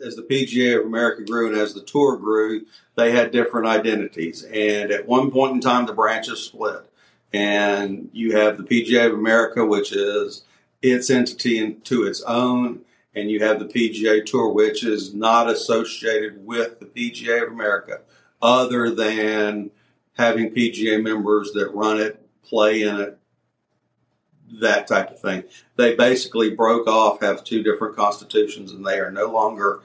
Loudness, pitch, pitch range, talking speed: -20 LUFS, 110 Hz, 105-120 Hz, 165 wpm